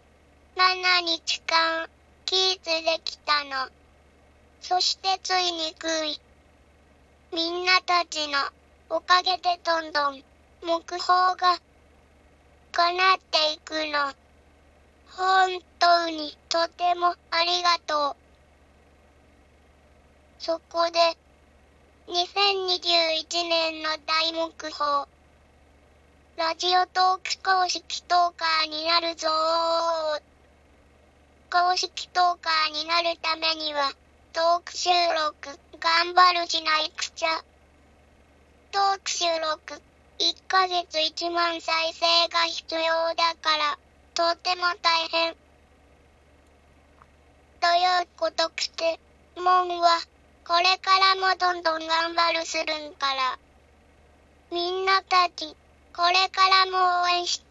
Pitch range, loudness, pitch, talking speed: 315-360 Hz, -24 LUFS, 335 Hz, 170 characters per minute